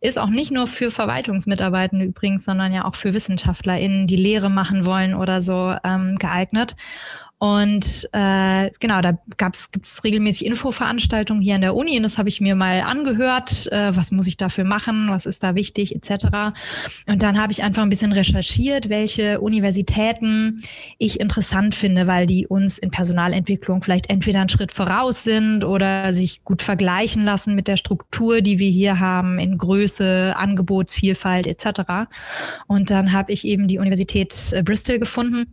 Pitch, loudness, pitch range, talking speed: 195 Hz, -19 LUFS, 190-210 Hz, 170 wpm